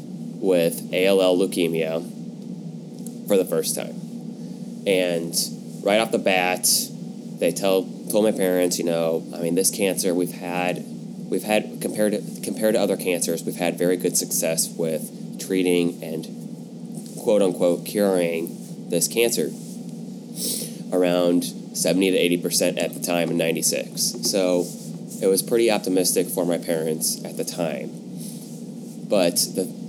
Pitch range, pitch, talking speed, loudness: 85-95 Hz, 90 Hz, 135 wpm, -22 LUFS